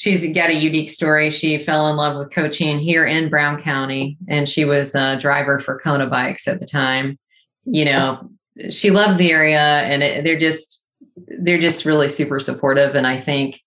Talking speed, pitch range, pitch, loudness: 195 wpm, 140-160 Hz, 150 Hz, -17 LUFS